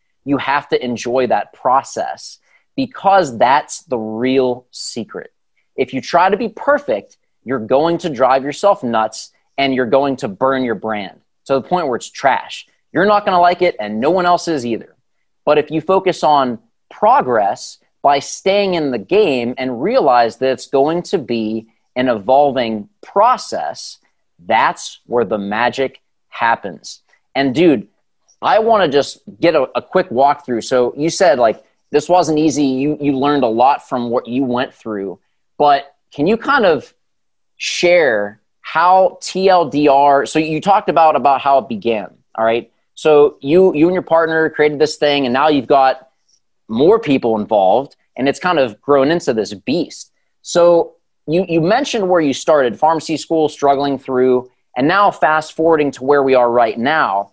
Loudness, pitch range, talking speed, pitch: -15 LUFS, 125-165 Hz, 175 wpm, 140 Hz